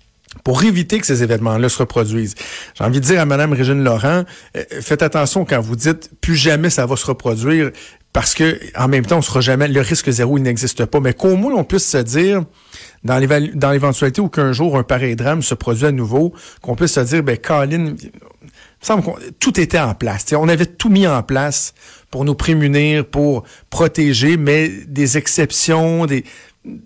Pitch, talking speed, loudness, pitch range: 145 Hz, 195 wpm, -15 LUFS, 130-165 Hz